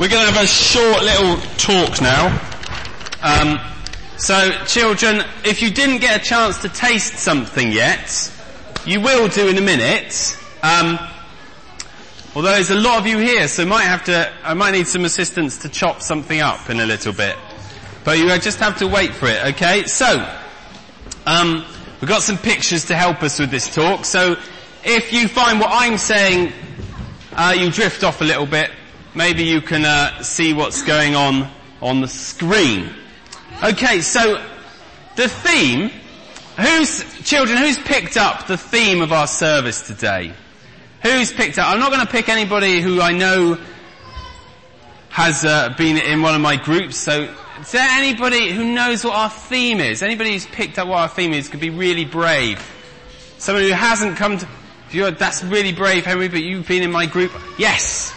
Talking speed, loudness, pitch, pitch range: 175 wpm, -15 LUFS, 185 Hz, 160-220 Hz